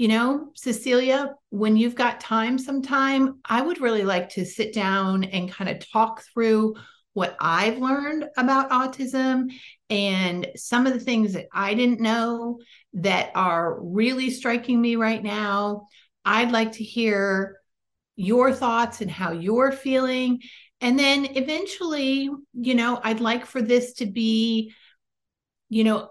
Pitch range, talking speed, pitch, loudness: 215-260 Hz, 145 wpm, 235 Hz, -23 LUFS